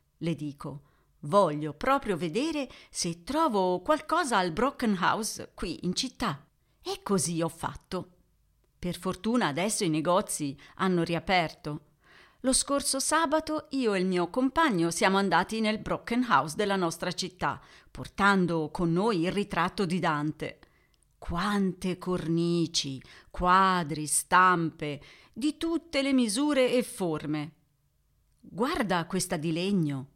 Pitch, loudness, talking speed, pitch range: 180 Hz, -28 LUFS, 120 wpm, 165-235 Hz